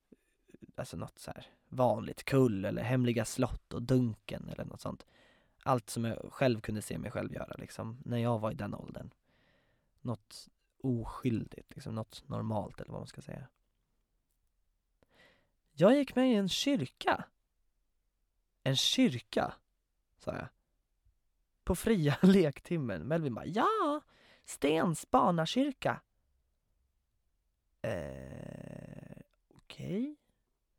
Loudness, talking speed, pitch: -33 LUFS, 120 wpm, 130 Hz